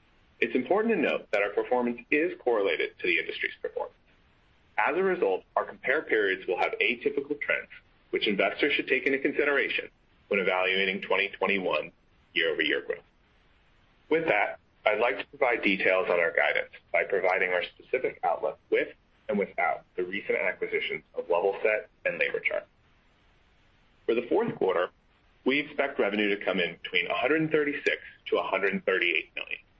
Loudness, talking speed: -28 LUFS, 155 wpm